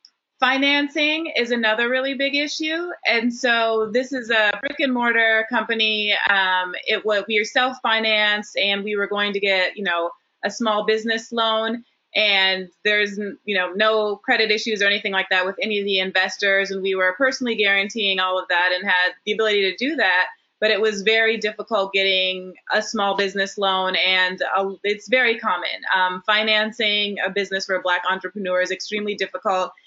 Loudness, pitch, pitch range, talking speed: -20 LUFS, 210 Hz, 190-225 Hz, 180 wpm